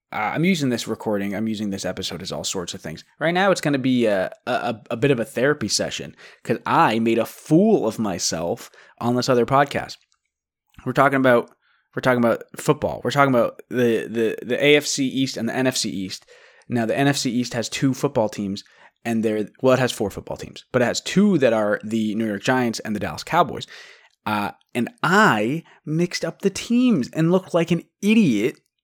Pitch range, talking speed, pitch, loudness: 110-150 Hz, 210 wpm, 125 Hz, -21 LUFS